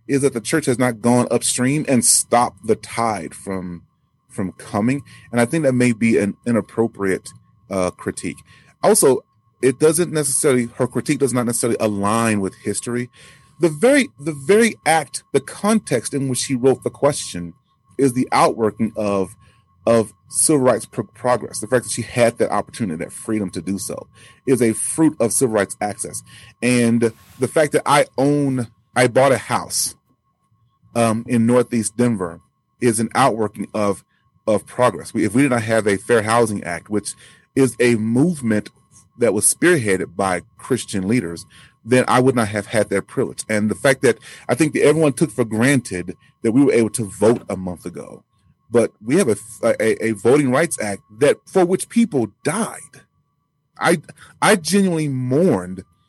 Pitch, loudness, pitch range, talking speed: 120 Hz, -19 LUFS, 110-135 Hz, 175 wpm